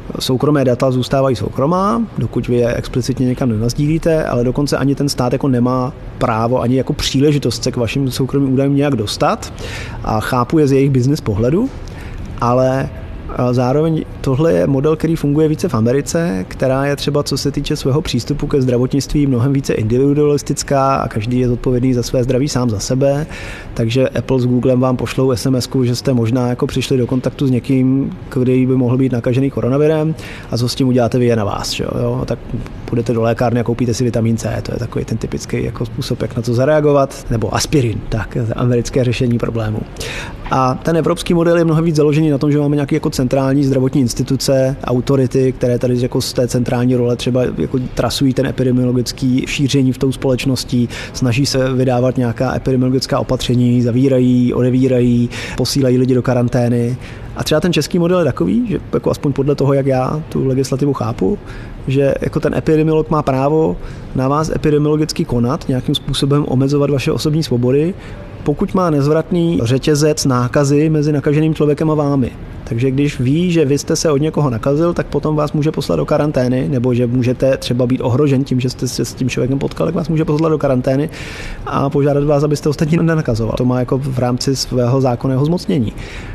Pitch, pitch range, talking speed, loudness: 130 Hz, 125-145 Hz, 185 wpm, -15 LUFS